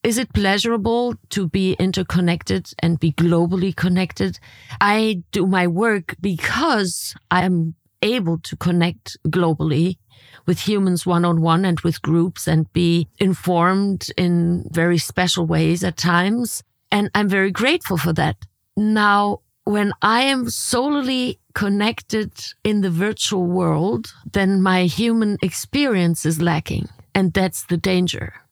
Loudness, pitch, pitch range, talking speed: -19 LUFS, 180 Hz, 170-205 Hz, 135 wpm